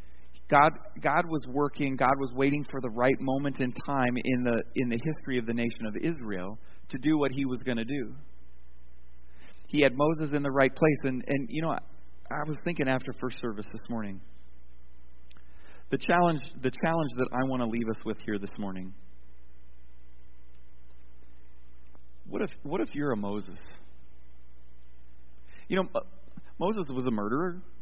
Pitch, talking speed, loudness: 115 Hz, 170 wpm, -30 LUFS